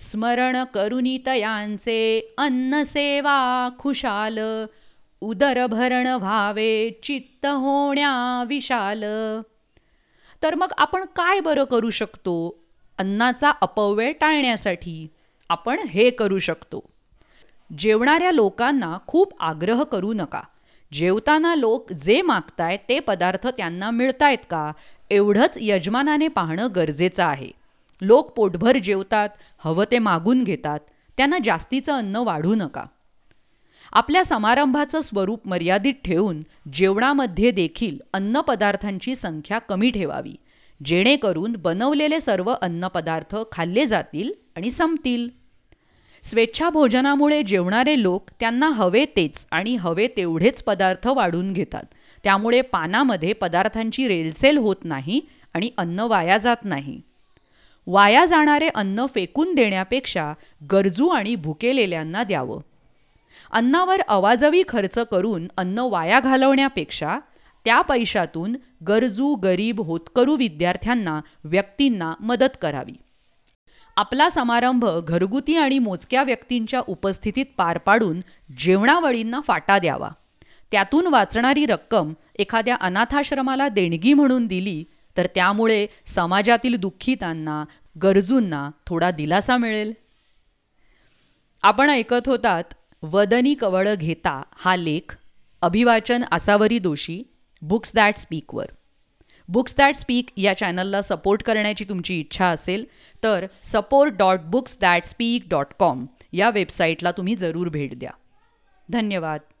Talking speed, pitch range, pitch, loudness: 105 wpm, 185-255 Hz, 220 Hz, -21 LUFS